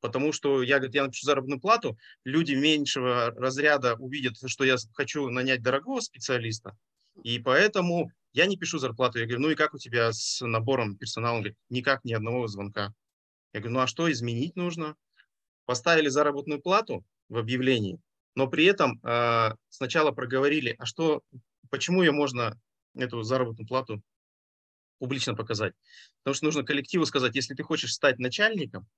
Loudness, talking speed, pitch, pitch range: -27 LUFS, 160 wpm, 130 Hz, 120-150 Hz